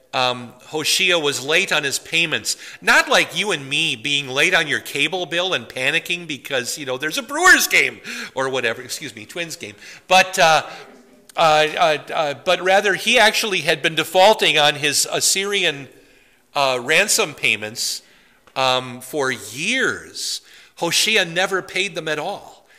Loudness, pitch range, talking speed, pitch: -17 LUFS, 135-185 Hz, 160 wpm, 155 Hz